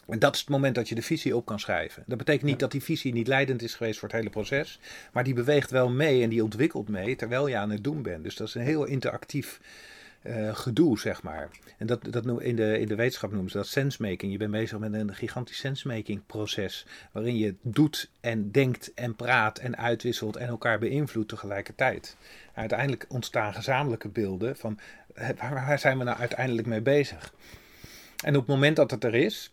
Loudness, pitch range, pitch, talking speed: -28 LUFS, 110-135 Hz, 120 Hz, 220 wpm